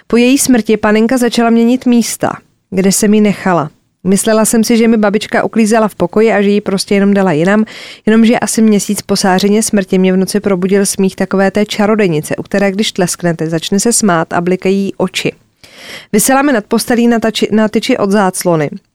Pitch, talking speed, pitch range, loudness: 210 Hz, 185 wpm, 190-225 Hz, -11 LUFS